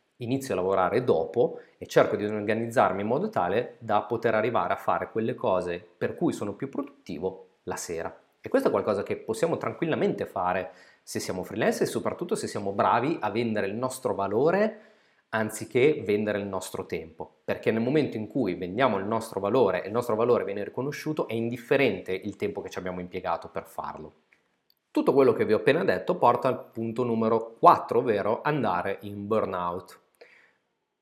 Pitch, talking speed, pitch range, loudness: 110 Hz, 180 wpm, 95-120 Hz, -27 LUFS